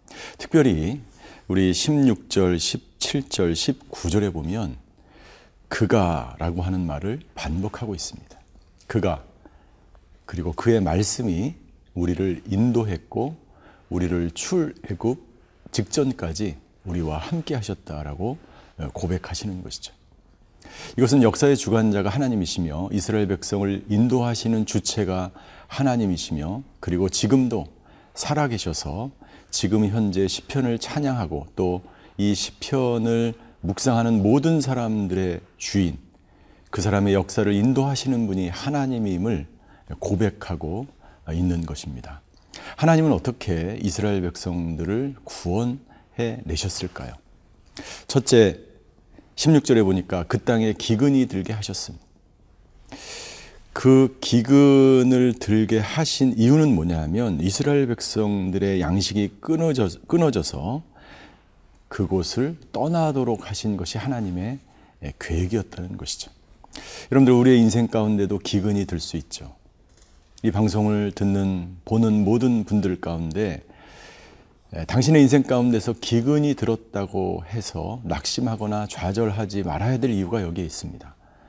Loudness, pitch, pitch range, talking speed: -22 LUFS, 105 Hz, 90-120 Hz, 260 characters per minute